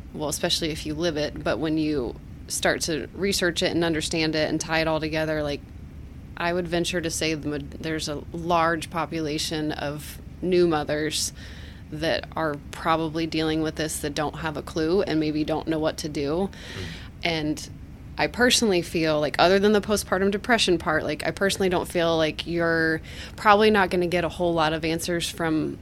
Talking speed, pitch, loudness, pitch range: 190 wpm, 160 Hz, -24 LUFS, 150-175 Hz